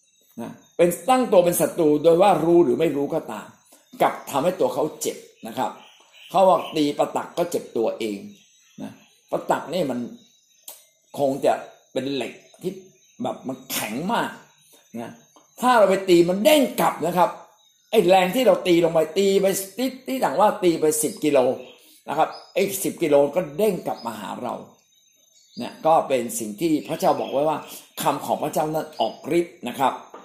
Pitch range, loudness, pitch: 155-210 Hz, -22 LUFS, 175 Hz